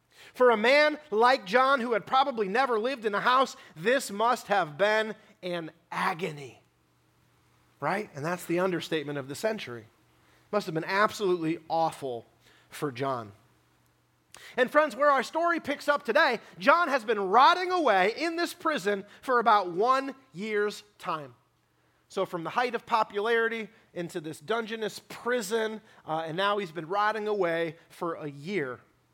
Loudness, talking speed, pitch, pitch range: -27 LUFS, 155 wpm, 205 Hz, 160-240 Hz